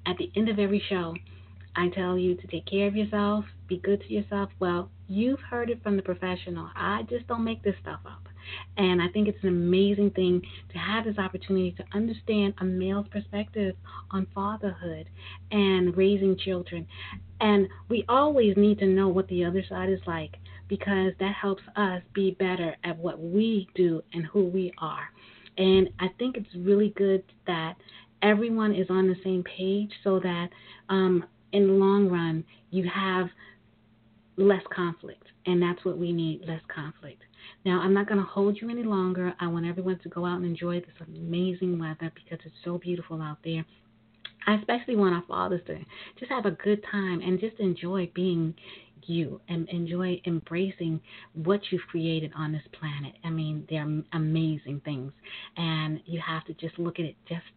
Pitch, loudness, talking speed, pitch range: 180 Hz, -28 LUFS, 180 wpm, 165-200 Hz